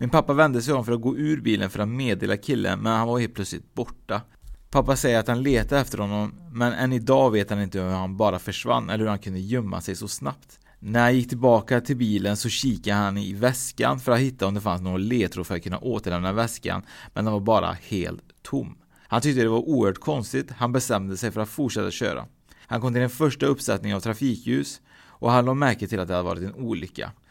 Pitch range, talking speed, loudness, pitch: 100-125 Hz, 235 wpm, -24 LUFS, 115 Hz